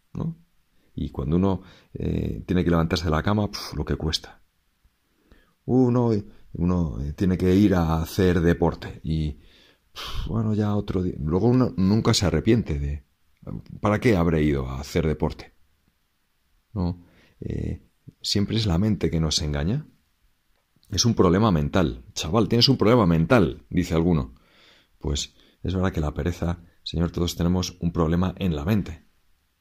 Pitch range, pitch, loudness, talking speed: 80-100 Hz, 85 Hz, -24 LUFS, 155 wpm